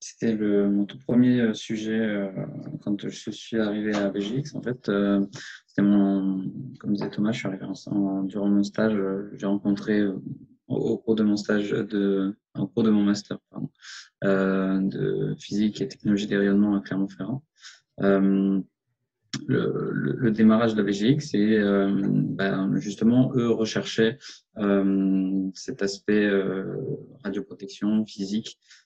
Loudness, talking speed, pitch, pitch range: -25 LUFS, 155 wpm, 100 Hz, 100-110 Hz